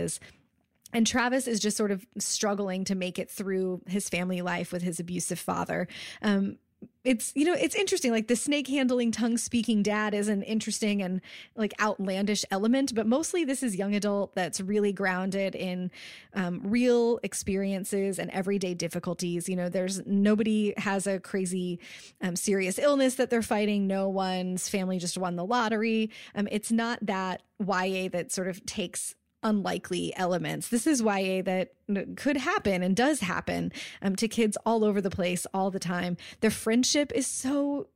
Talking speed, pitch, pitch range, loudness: 170 wpm, 200 Hz, 185-230 Hz, -29 LUFS